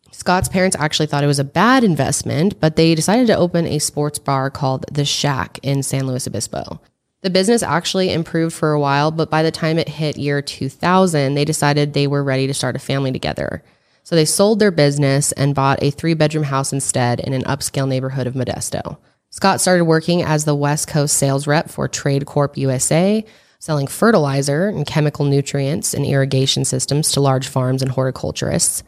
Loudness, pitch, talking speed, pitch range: -17 LUFS, 145 Hz, 195 wpm, 135-160 Hz